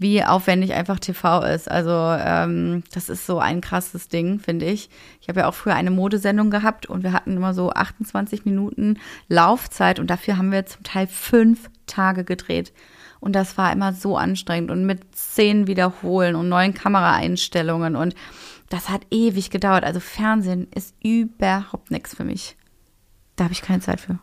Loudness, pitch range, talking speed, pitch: -21 LUFS, 180-200 Hz, 175 wpm, 190 Hz